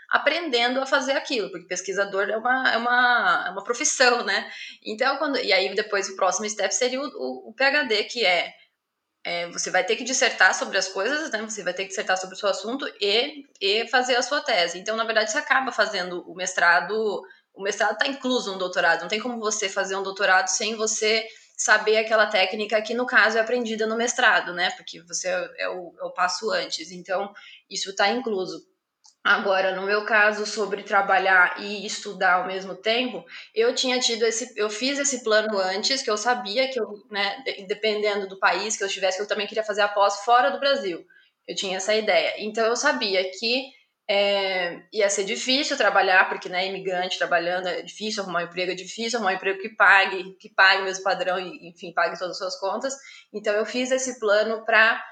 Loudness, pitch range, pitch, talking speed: -23 LUFS, 190-245 Hz, 210 Hz, 210 wpm